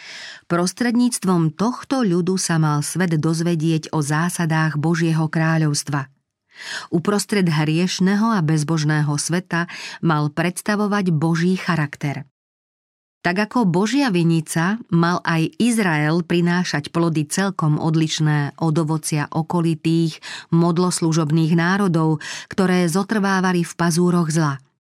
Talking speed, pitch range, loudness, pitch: 100 wpm, 160-185 Hz, -19 LUFS, 170 Hz